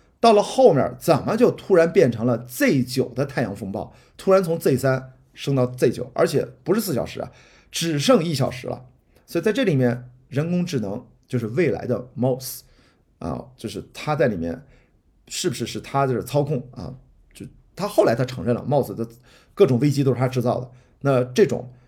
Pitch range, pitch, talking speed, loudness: 125-145 Hz, 130 Hz, 275 characters per minute, -22 LUFS